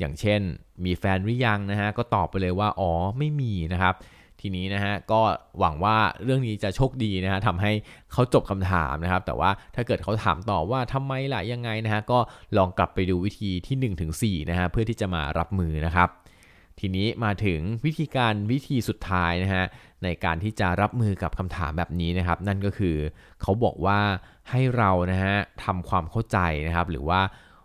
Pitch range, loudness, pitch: 90-110 Hz, -26 LUFS, 95 Hz